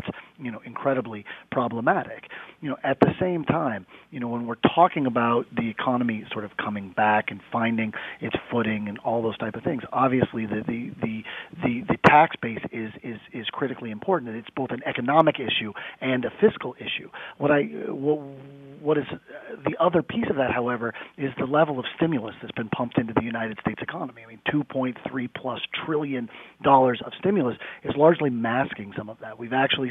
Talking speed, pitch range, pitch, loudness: 195 wpm, 115-145 Hz, 130 Hz, -25 LUFS